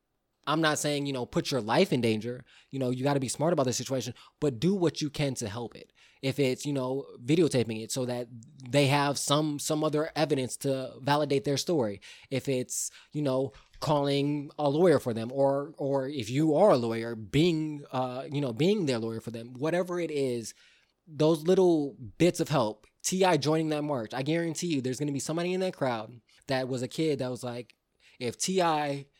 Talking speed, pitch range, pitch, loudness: 210 wpm, 125-155 Hz, 140 Hz, -29 LUFS